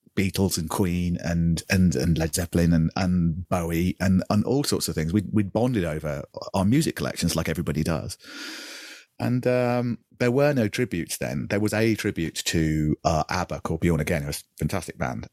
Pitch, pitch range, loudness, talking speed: 90 Hz, 80-105 Hz, -25 LUFS, 190 wpm